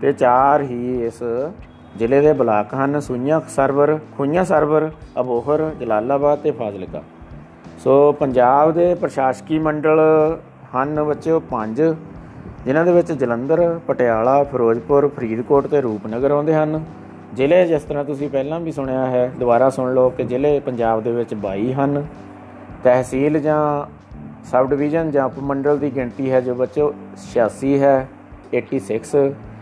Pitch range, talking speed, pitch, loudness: 125-150 Hz, 135 wpm, 140 Hz, -18 LUFS